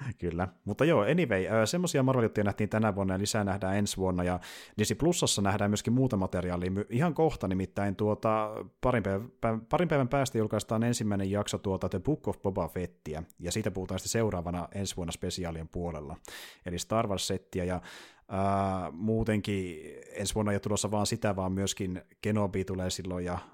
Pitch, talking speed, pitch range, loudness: 100 Hz, 170 wpm, 95-110 Hz, -31 LUFS